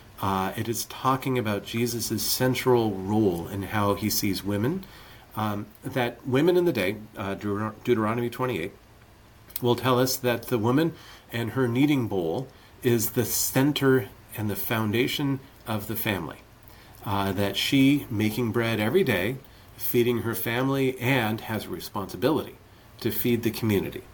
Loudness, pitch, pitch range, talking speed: -26 LUFS, 115 Hz, 105-125 Hz, 150 wpm